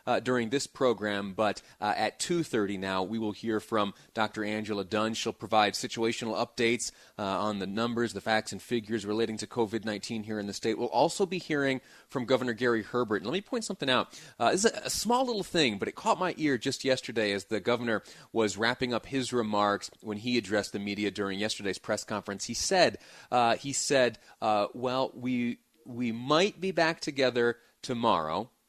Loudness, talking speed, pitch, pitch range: -30 LUFS, 200 wpm, 115 Hz, 105-125 Hz